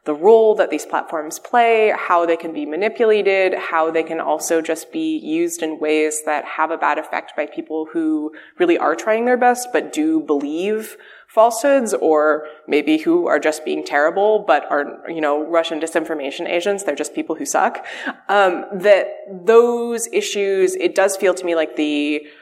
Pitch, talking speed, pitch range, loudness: 180 Hz, 180 wpm, 155-235 Hz, -18 LUFS